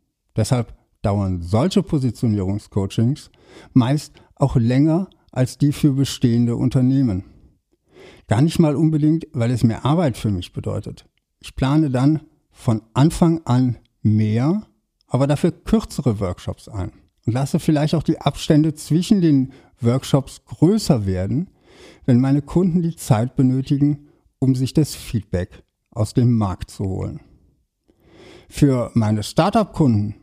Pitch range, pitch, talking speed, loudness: 110-155 Hz, 130 Hz, 125 wpm, -20 LUFS